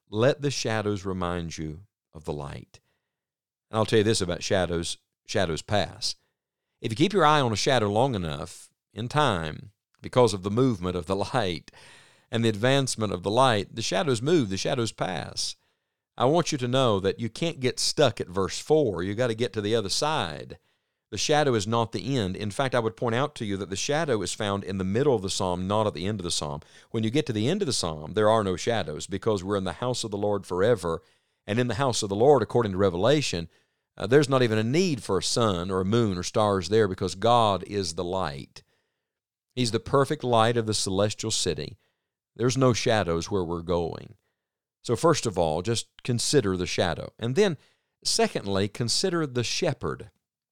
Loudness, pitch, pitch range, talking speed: -26 LUFS, 110 Hz, 95-125 Hz, 215 wpm